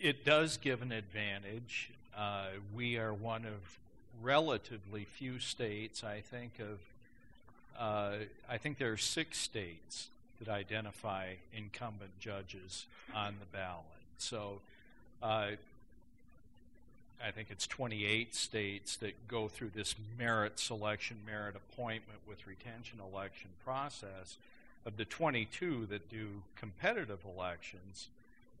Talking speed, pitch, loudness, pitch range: 115 wpm, 105 Hz, -40 LUFS, 100-115 Hz